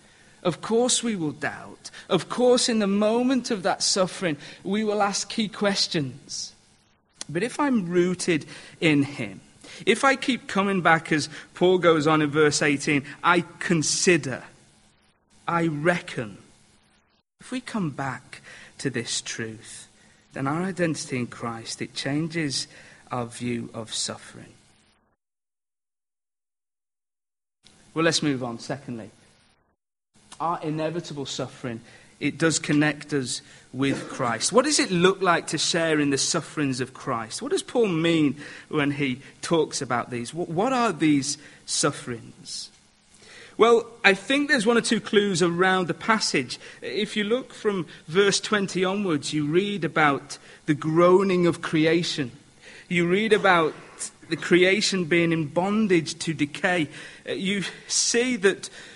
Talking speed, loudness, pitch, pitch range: 135 wpm, -24 LUFS, 165 Hz, 140-195 Hz